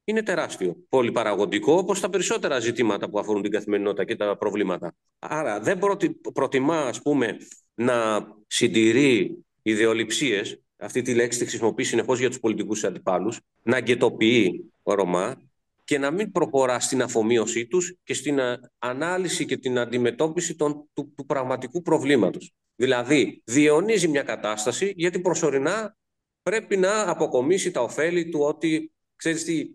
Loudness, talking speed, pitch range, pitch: -24 LUFS, 135 wpm, 115-175 Hz, 145 Hz